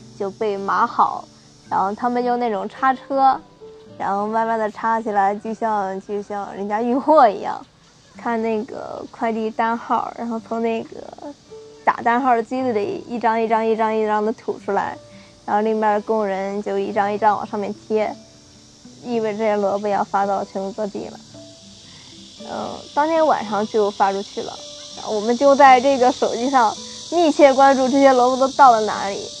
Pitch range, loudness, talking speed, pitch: 200-245 Hz, -19 LUFS, 260 characters per minute, 220 Hz